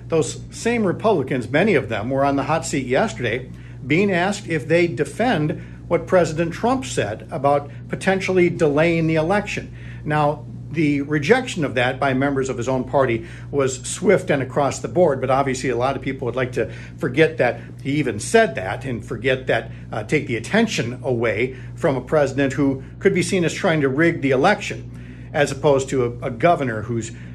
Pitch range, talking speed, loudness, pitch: 125-160 Hz, 190 wpm, -20 LUFS, 135 Hz